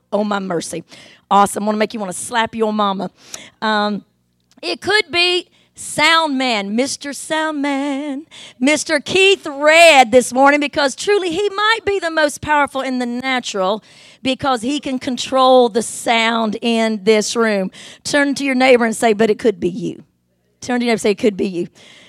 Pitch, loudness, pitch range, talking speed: 250 Hz, -16 LUFS, 215-290 Hz, 185 wpm